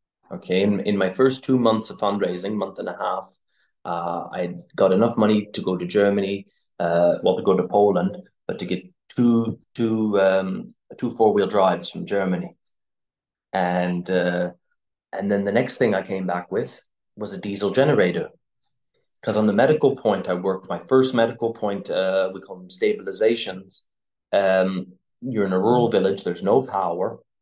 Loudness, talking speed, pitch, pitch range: -22 LUFS, 175 wpm, 95 Hz, 90-110 Hz